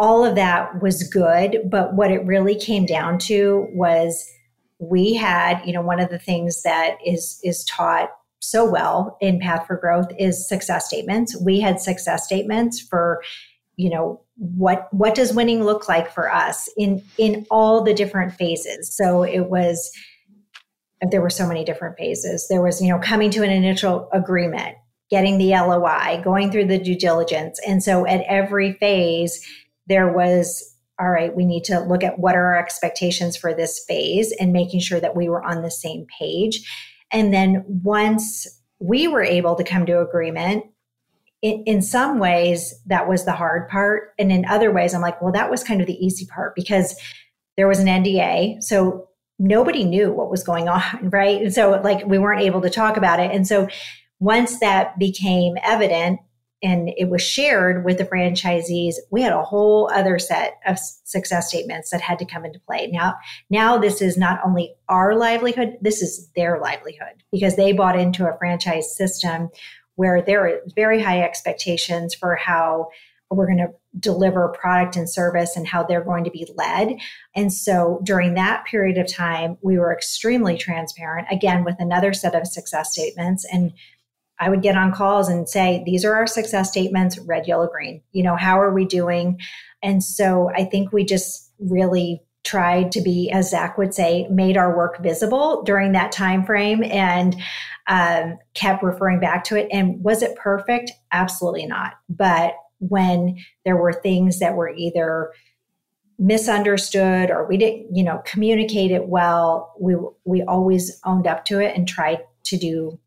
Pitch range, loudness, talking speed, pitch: 175-200 Hz, -19 LUFS, 180 wpm, 185 Hz